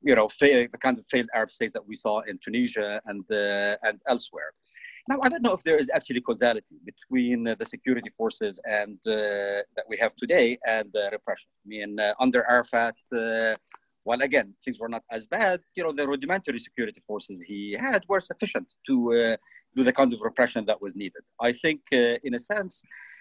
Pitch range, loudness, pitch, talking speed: 105-160 Hz, -26 LUFS, 120 Hz, 205 wpm